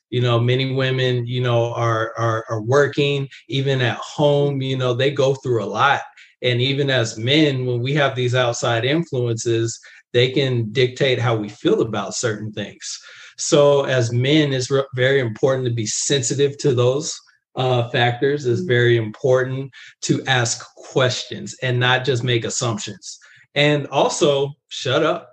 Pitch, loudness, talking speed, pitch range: 125 Hz, -19 LUFS, 160 wpm, 120-140 Hz